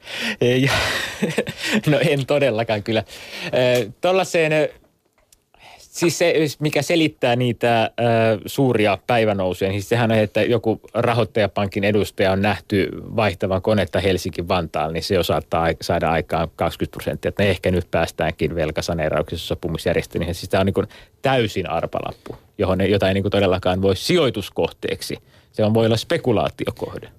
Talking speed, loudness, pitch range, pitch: 130 wpm, -20 LUFS, 95-125 Hz, 105 Hz